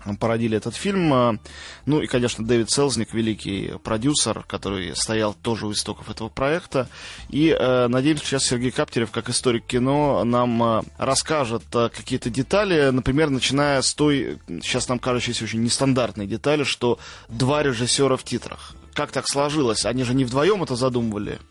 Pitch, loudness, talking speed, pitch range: 125 Hz, -22 LUFS, 150 wpm, 110-135 Hz